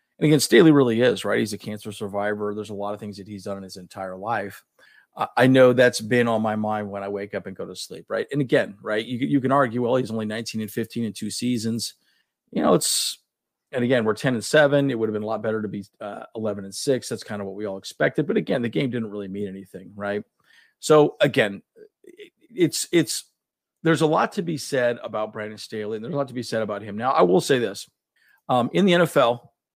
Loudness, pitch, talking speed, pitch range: -23 LUFS, 110 Hz, 245 wpm, 105-140 Hz